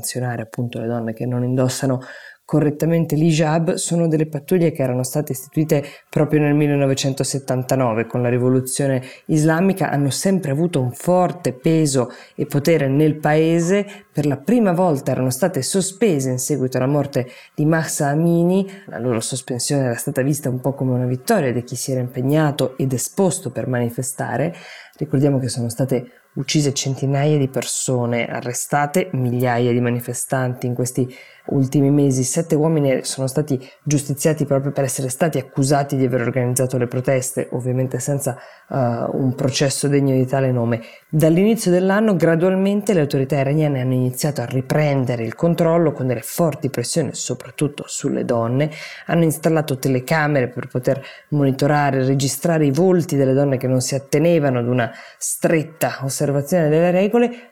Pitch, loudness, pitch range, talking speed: 140 Hz, -19 LUFS, 130-155 Hz, 155 wpm